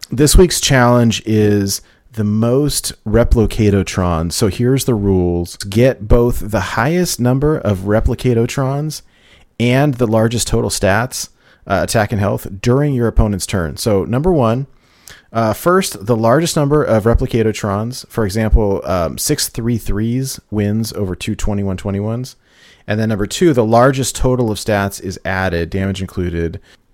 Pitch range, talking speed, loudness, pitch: 100-125 Hz, 150 wpm, -15 LUFS, 115 Hz